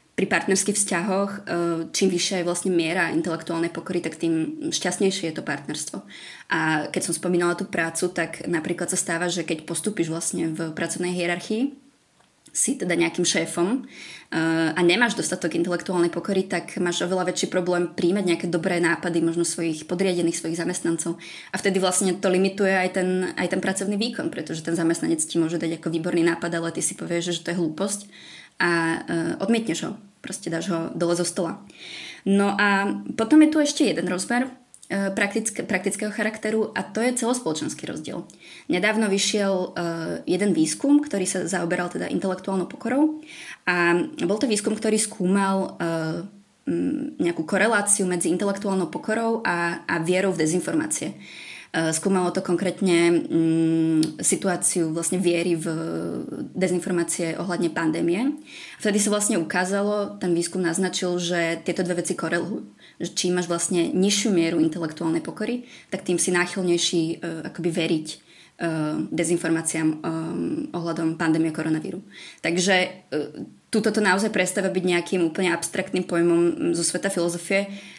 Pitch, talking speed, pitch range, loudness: 180 Hz, 150 wpm, 170-195 Hz, -24 LUFS